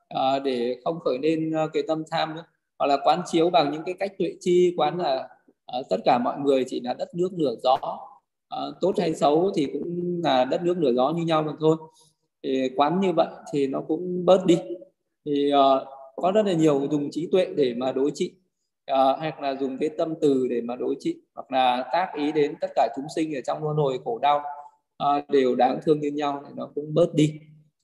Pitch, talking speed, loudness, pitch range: 155 Hz, 235 wpm, -24 LUFS, 140-170 Hz